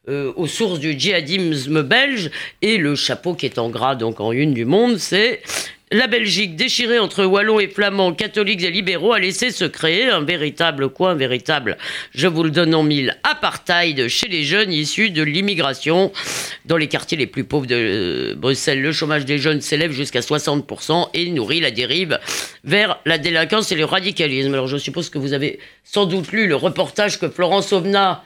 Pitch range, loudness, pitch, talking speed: 145-195 Hz, -18 LUFS, 165 Hz, 190 wpm